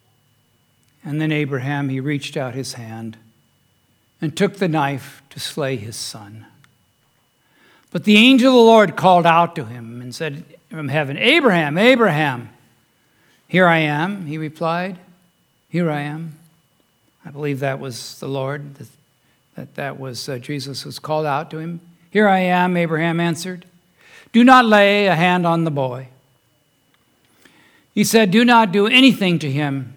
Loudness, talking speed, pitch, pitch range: -17 LUFS, 155 wpm, 150 Hz, 135-175 Hz